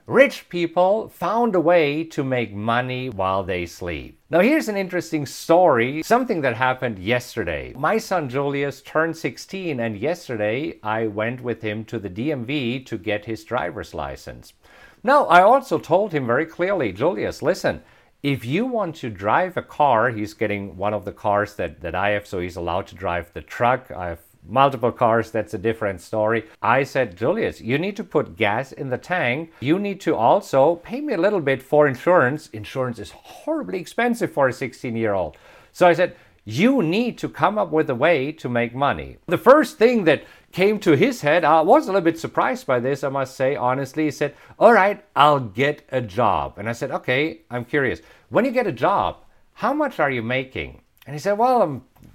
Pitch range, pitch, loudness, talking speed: 110-170 Hz, 135 Hz, -21 LUFS, 200 wpm